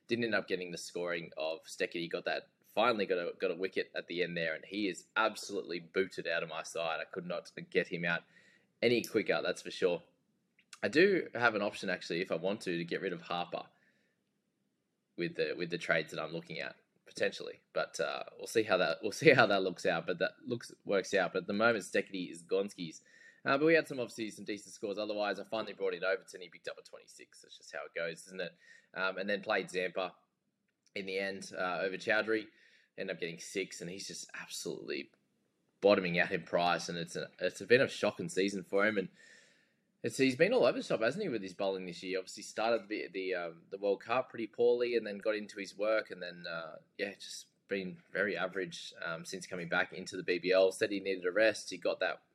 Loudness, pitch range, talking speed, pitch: -35 LUFS, 95-155 Hz, 235 wpm, 105 Hz